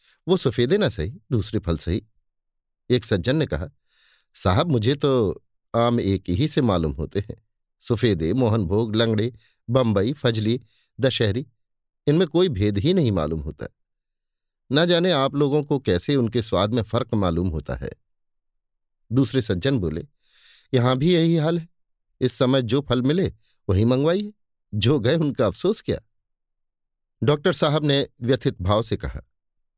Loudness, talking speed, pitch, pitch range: -22 LUFS, 150 wpm, 120 Hz, 105-140 Hz